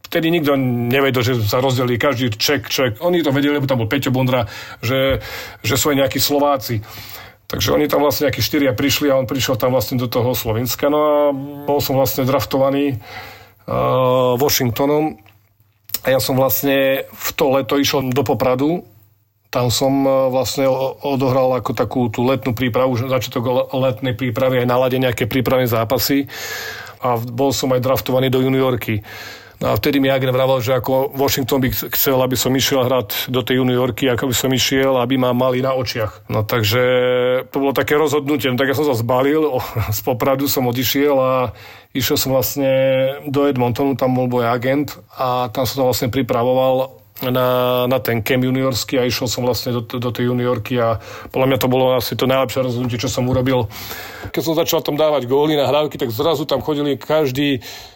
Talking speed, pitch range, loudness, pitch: 185 wpm, 125-140 Hz, -17 LUFS, 130 Hz